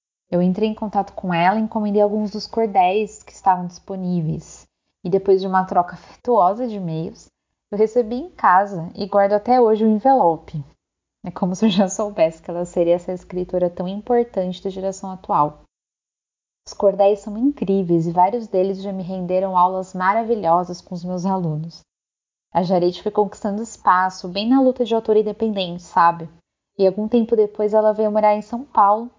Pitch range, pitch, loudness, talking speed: 180-215 Hz, 195 Hz, -19 LUFS, 180 wpm